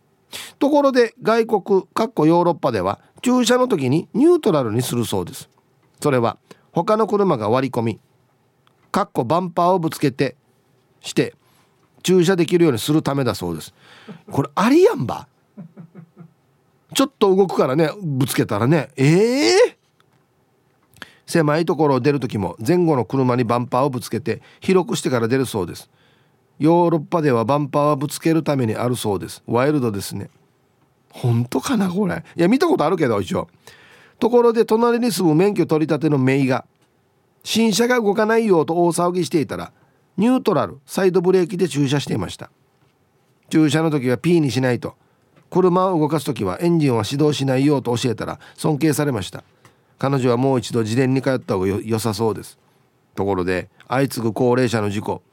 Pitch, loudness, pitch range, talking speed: 145 Hz, -19 LUFS, 125-180 Hz, 350 characters per minute